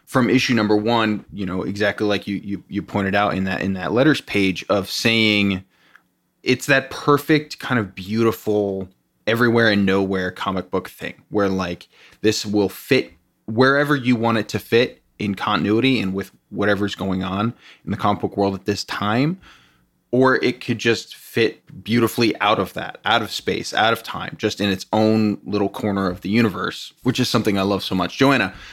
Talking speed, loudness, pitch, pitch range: 190 wpm, -20 LUFS, 105 Hz, 95-115 Hz